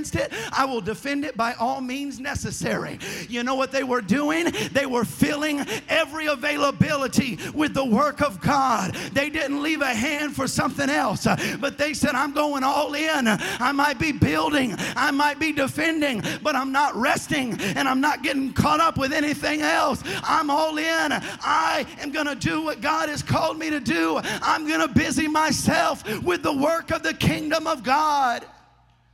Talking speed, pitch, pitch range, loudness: 180 wpm, 290 Hz, 265-310 Hz, -23 LUFS